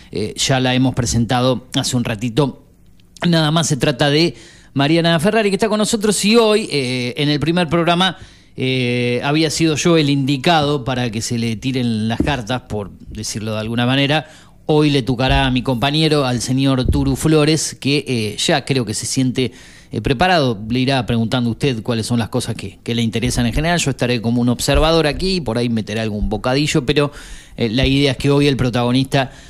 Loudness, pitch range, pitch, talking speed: -17 LUFS, 120-150 Hz, 130 Hz, 200 wpm